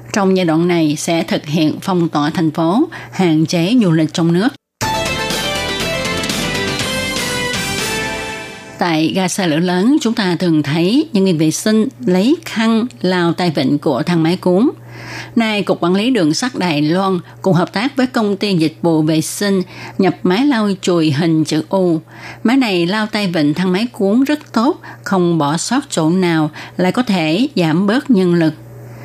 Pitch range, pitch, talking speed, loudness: 160-205 Hz, 180 Hz, 180 wpm, -15 LUFS